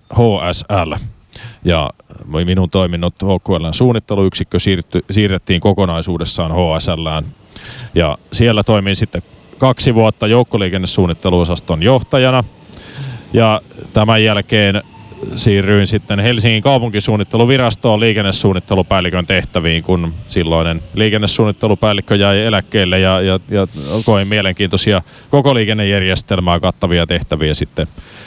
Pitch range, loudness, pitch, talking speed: 90-110 Hz, -13 LUFS, 100 Hz, 85 wpm